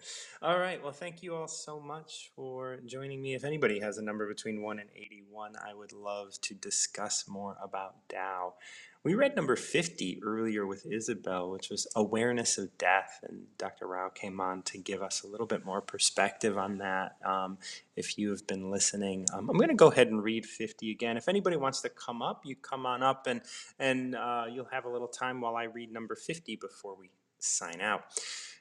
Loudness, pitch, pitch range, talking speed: -33 LUFS, 110 Hz, 100-130 Hz, 205 wpm